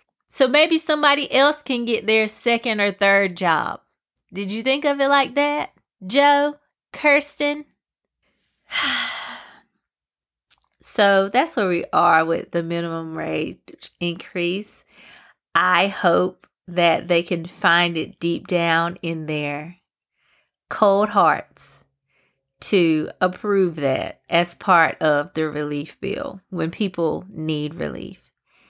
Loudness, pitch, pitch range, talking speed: -20 LUFS, 185 Hz, 165-235 Hz, 115 wpm